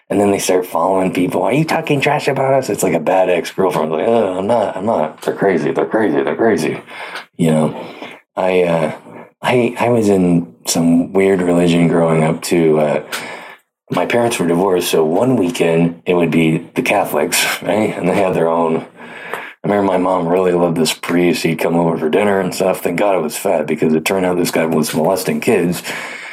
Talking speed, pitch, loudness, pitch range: 205 wpm, 90 Hz, -15 LUFS, 85-95 Hz